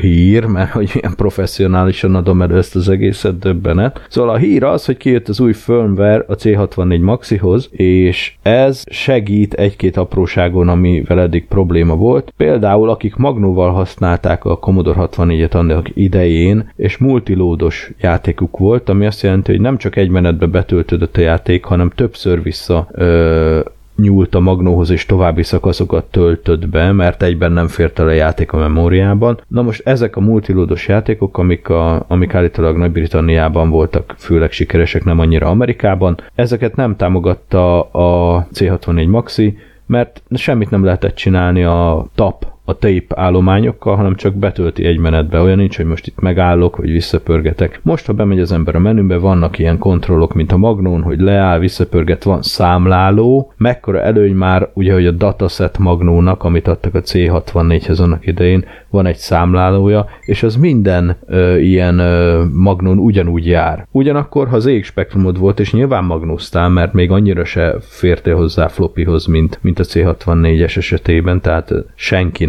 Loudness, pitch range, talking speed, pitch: -12 LUFS, 85-100 Hz, 155 wpm, 90 Hz